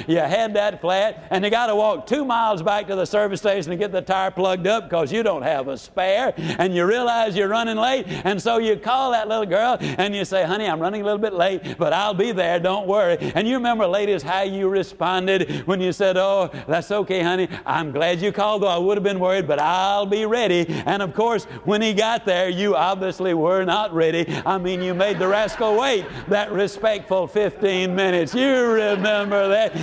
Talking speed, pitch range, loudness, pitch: 225 wpm, 185-215 Hz, -21 LUFS, 200 Hz